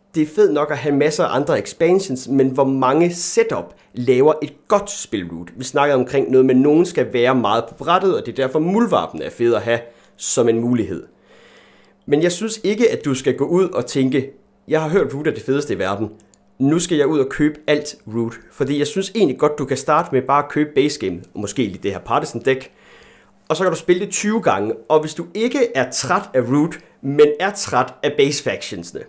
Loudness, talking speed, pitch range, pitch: -18 LUFS, 235 wpm, 130-175 Hz, 145 Hz